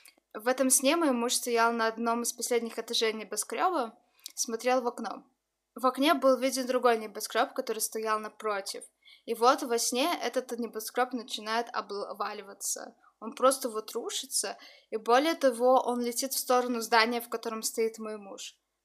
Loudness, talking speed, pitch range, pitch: -29 LUFS, 155 wpm, 225-260 Hz, 240 Hz